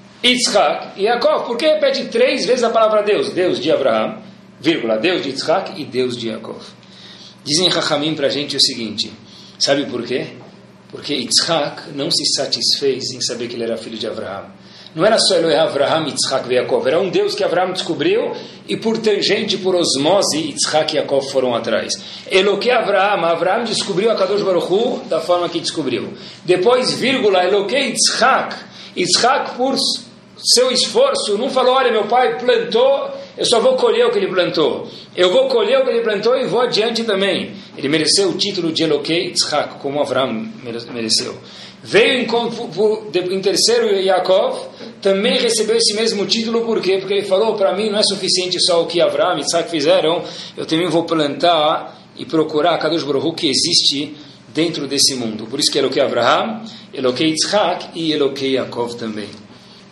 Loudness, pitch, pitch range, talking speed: -16 LUFS, 195 Hz, 155-240 Hz, 175 wpm